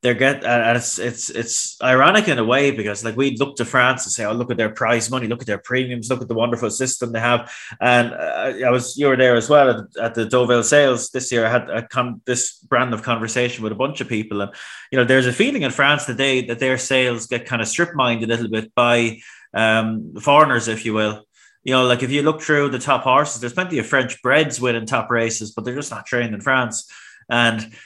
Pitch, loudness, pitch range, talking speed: 120 Hz, -18 LUFS, 115-130 Hz, 250 wpm